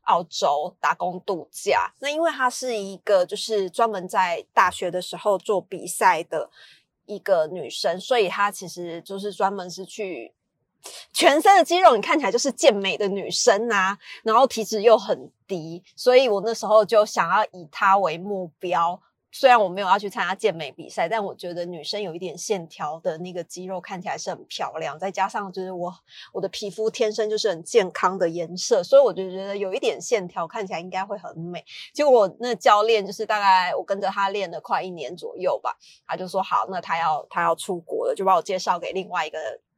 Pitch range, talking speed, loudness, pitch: 185-225 Hz, 300 characters per minute, -22 LUFS, 200 Hz